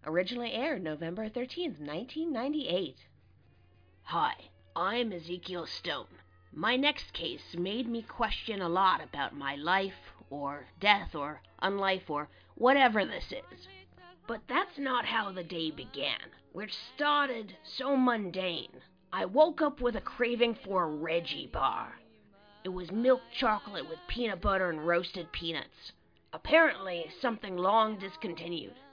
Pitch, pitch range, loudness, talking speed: 195 Hz, 165-245 Hz, -32 LUFS, 130 wpm